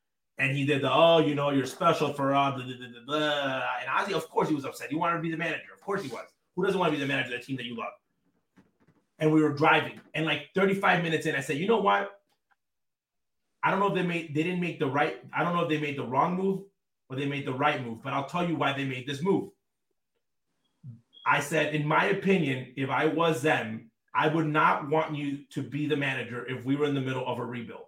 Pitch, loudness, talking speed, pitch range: 150 Hz, -28 LUFS, 260 wpm, 135-160 Hz